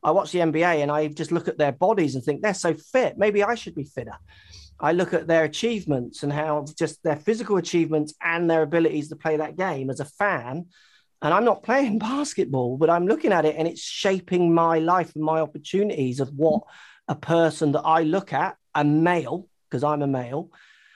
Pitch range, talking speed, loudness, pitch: 150-180 Hz, 210 wpm, -23 LUFS, 160 Hz